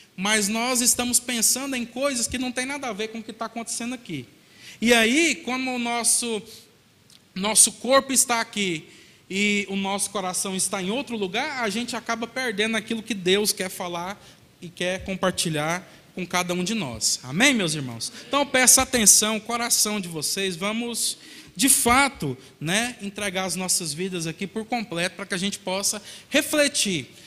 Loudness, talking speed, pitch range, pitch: -22 LUFS, 175 wpm, 185-240 Hz, 215 Hz